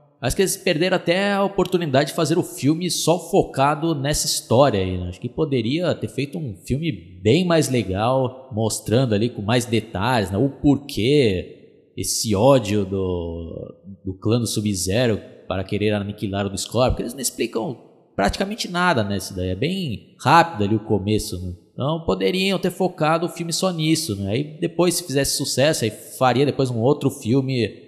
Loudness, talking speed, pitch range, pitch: -21 LUFS, 180 wpm, 105-160 Hz, 130 Hz